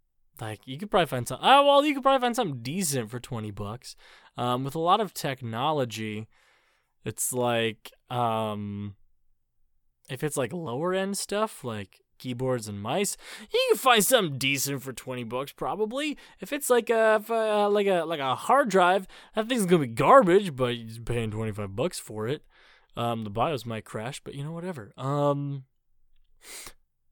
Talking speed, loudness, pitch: 180 wpm, -26 LUFS, 135 Hz